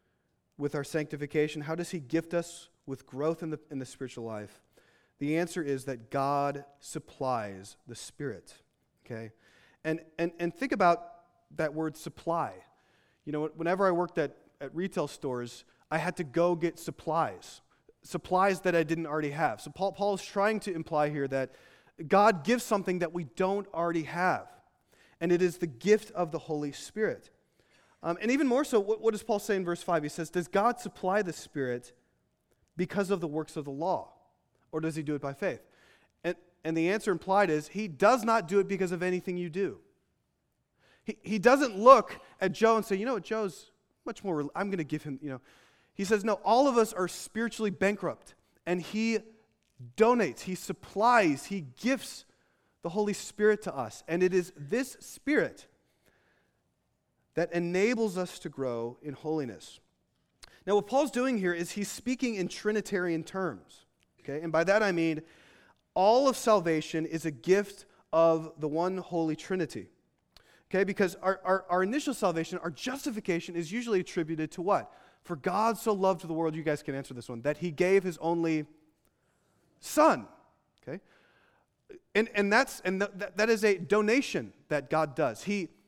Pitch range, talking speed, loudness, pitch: 155-205 Hz, 180 wpm, -30 LUFS, 175 Hz